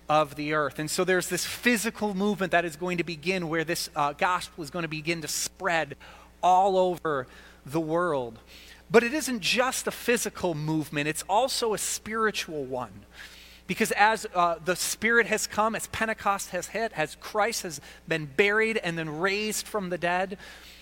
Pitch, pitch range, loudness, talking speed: 180 Hz, 155-210 Hz, -27 LUFS, 180 wpm